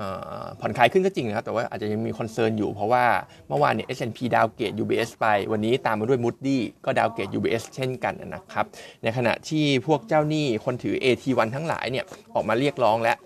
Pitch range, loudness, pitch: 115-140 Hz, -25 LUFS, 125 Hz